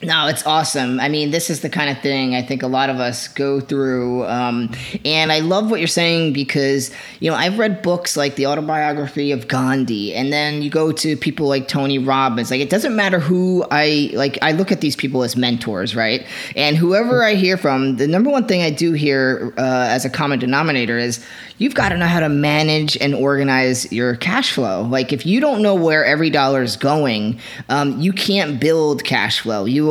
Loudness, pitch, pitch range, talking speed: -17 LUFS, 145 Hz, 130-160 Hz, 215 wpm